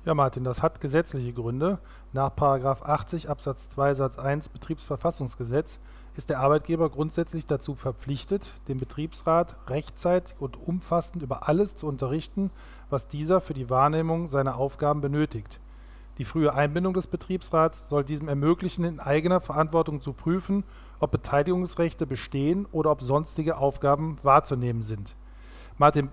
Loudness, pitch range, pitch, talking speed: -27 LUFS, 135-165 Hz, 150 Hz, 135 wpm